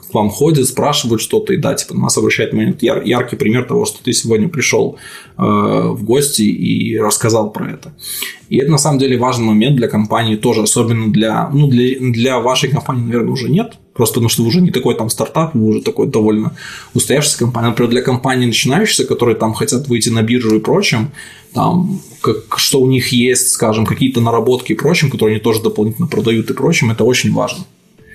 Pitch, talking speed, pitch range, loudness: 120 Hz, 195 wpm, 110-130 Hz, -13 LUFS